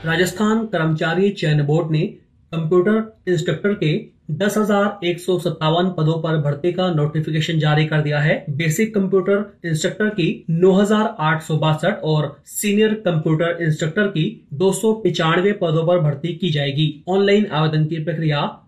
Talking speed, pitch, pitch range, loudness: 155 wpm, 170 Hz, 155-195 Hz, -19 LUFS